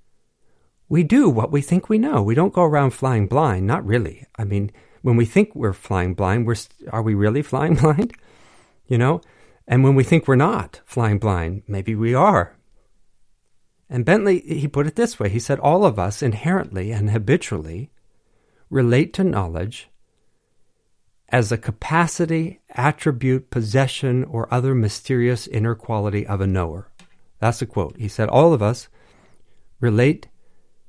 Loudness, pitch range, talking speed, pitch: -20 LUFS, 105-150 Hz, 160 wpm, 120 Hz